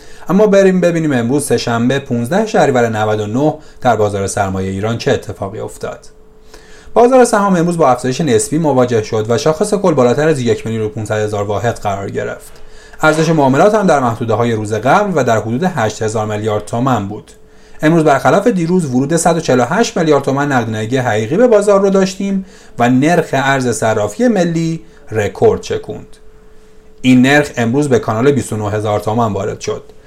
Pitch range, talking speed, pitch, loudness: 110-170 Hz, 160 wpm, 135 Hz, -13 LUFS